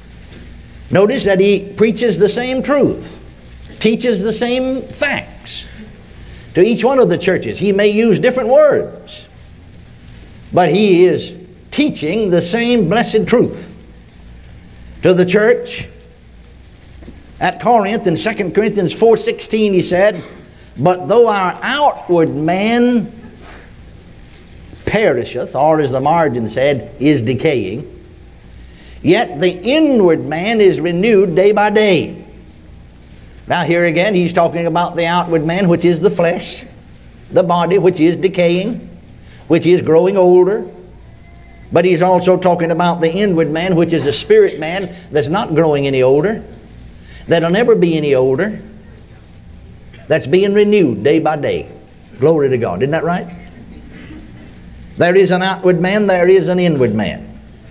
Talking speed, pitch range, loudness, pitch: 135 wpm, 150-205 Hz, -13 LUFS, 180 Hz